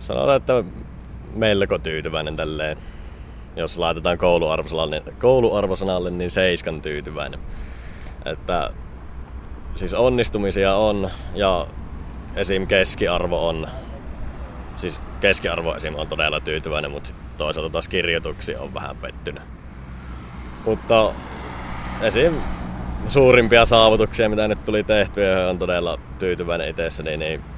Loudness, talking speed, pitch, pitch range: -21 LUFS, 105 wpm, 75 Hz, 70-95 Hz